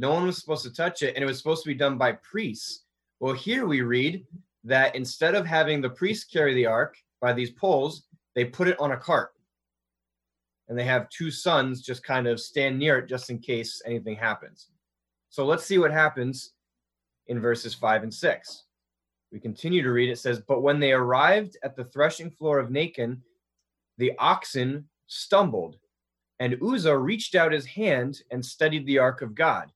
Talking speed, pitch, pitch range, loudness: 190 wpm, 130 Hz, 115-155 Hz, -25 LUFS